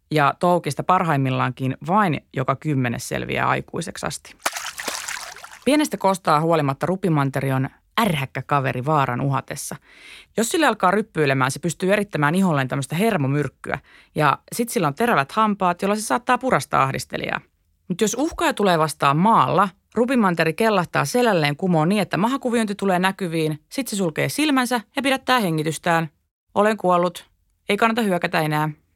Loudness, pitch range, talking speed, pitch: -21 LUFS, 145-215 Hz, 140 wpm, 175 Hz